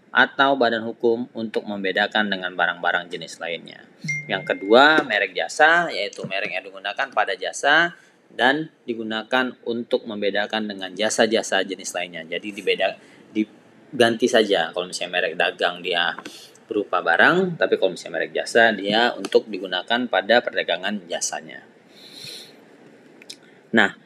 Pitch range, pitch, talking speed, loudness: 95-120 Hz, 110 Hz, 125 wpm, -21 LUFS